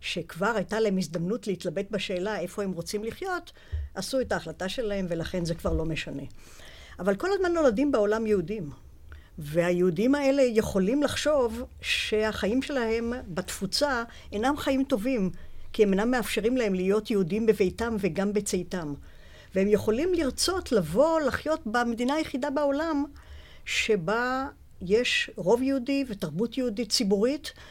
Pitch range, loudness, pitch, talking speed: 185-260 Hz, -27 LUFS, 215 Hz, 130 wpm